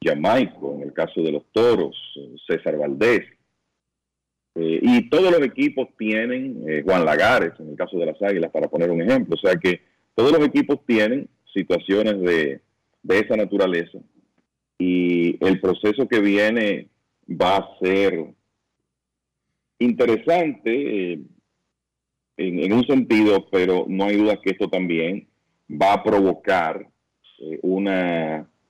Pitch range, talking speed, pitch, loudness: 85-120 Hz, 140 wpm, 95 Hz, -20 LUFS